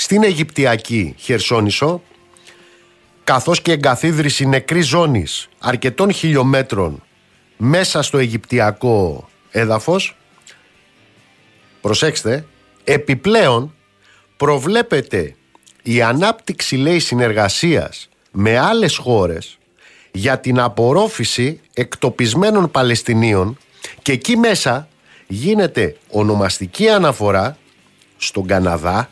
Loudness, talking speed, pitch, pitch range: -16 LUFS, 75 wpm, 130 Hz, 110-160 Hz